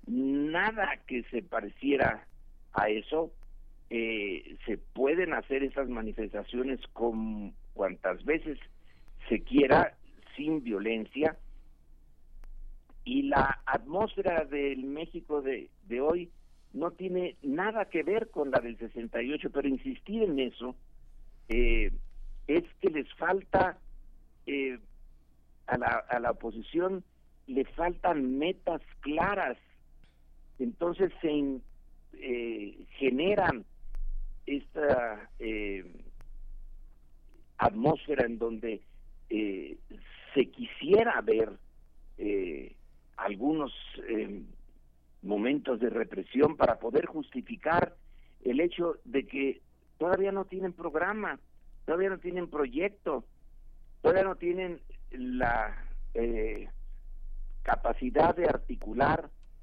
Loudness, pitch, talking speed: -31 LUFS, 120 Hz, 100 wpm